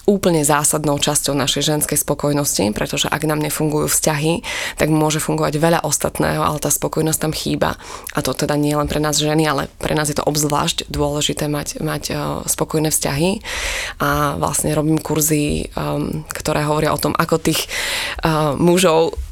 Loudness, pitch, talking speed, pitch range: -18 LUFS, 150 Hz, 160 wpm, 145-160 Hz